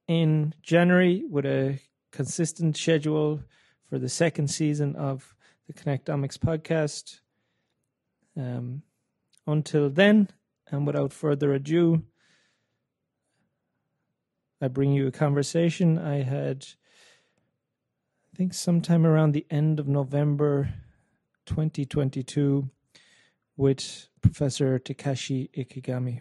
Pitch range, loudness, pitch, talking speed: 135-160 Hz, -26 LUFS, 145 Hz, 95 wpm